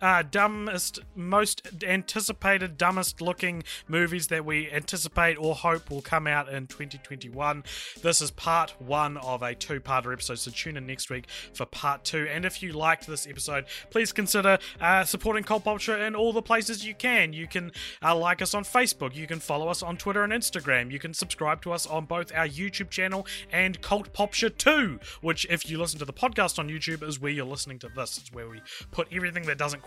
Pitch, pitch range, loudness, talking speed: 170 Hz, 145-195 Hz, -27 LUFS, 205 wpm